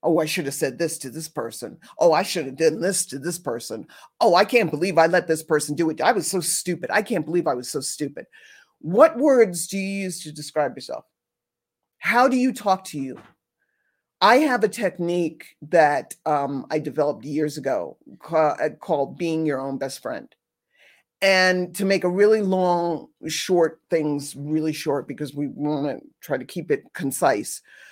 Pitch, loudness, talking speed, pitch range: 165 Hz, -22 LUFS, 190 wpm, 150-190 Hz